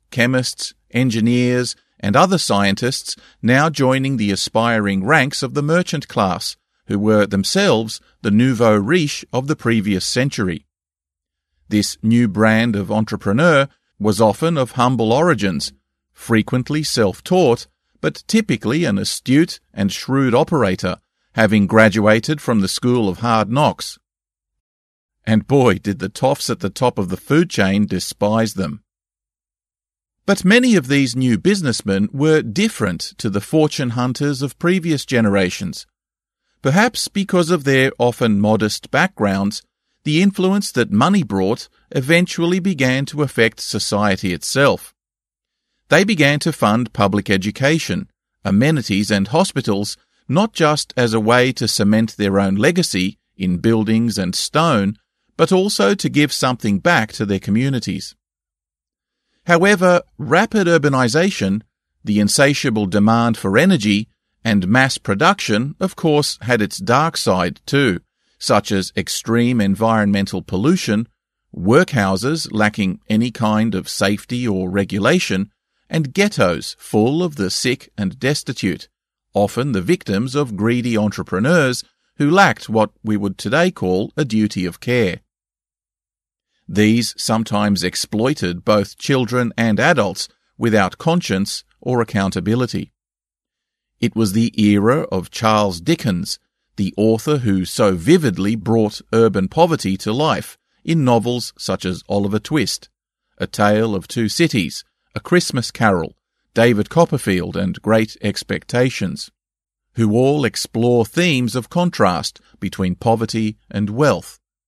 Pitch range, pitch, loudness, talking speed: 100-140 Hz, 115 Hz, -17 LUFS, 125 wpm